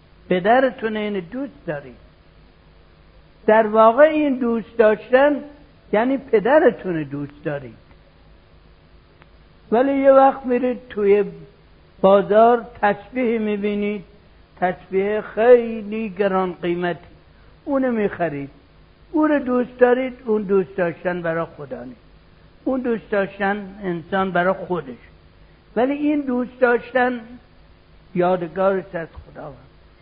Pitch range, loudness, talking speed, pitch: 175-245 Hz, -19 LUFS, 100 wpm, 205 Hz